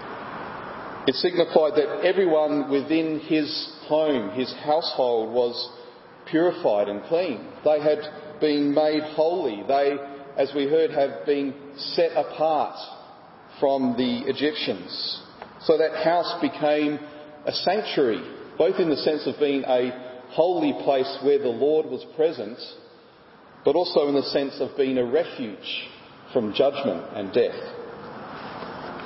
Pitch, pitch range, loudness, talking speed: 150 Hz, 135-155 Hz, -24 LUFS, 130 wpm